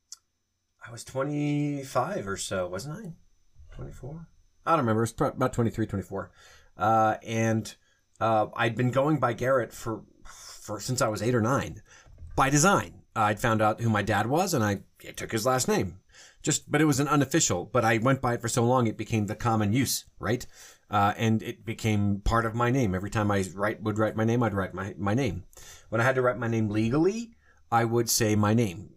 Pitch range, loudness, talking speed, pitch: 105-130 Hz, -27 LUFS, 210 wpm, 115 Hz